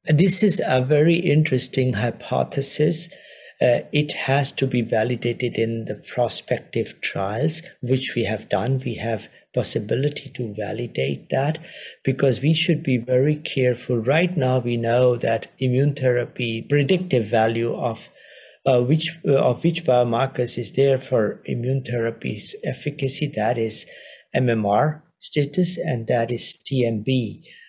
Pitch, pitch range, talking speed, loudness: 130 Hz, 120-145 Hz, 130 wpm, -22 LUFS